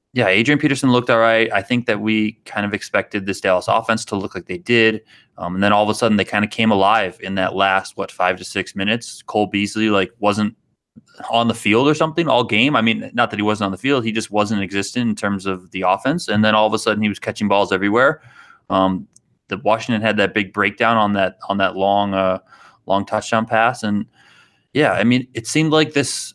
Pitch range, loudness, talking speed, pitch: 100-115 Hz, -18 LUFS, 240 wpm, 105 Hz